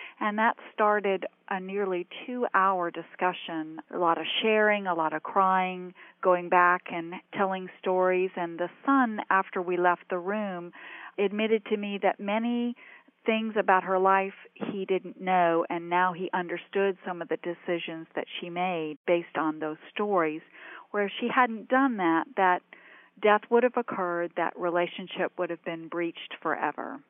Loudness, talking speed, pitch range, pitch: -28 LUFS, 165 wpm, 175-210 Hz, 185 Hz